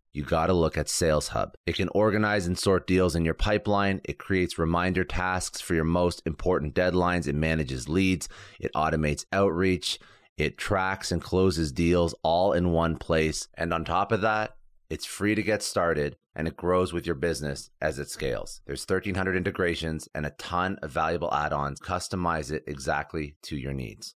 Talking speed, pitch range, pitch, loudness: 180 wpm, 80-95 Hz, 85 Hz, -27 LUFS